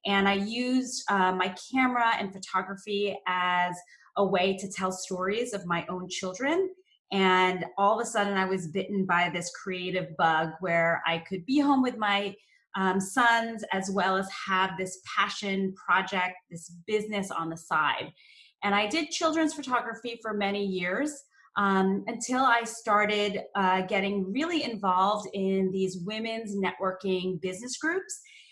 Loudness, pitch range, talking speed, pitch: -28 LUFS, 185-230 Hz, 155 wpm, 195 Hz